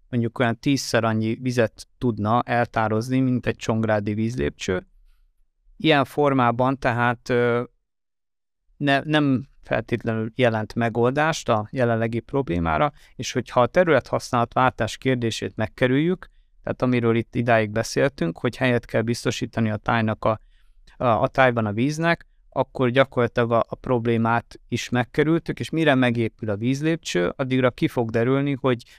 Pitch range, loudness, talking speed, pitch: 115-130 Hz, -23 LUFS, 130 wpm, 120 Hz